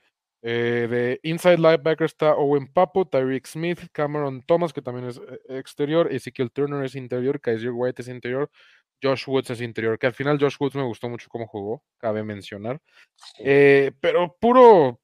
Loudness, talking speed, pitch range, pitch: -22 LUFS, 170 wpm, 125-150 Hz, 135 Hz